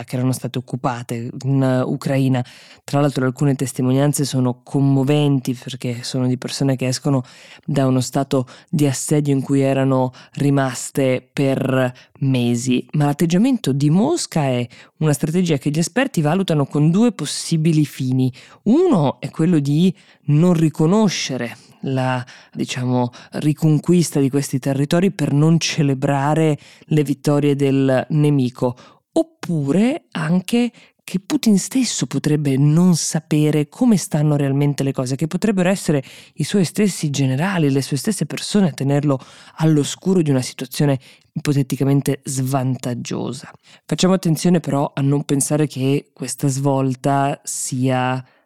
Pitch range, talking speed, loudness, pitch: 130-160 Hz, 130 wpm, -19 LUFS, 145 Hz